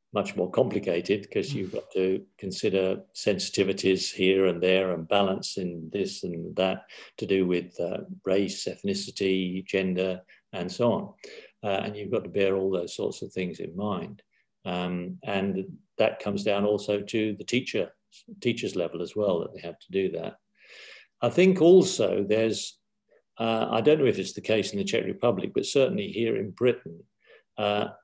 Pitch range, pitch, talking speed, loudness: 95-110 Hz, 95 Hz, 175 wpm, -27 LUFS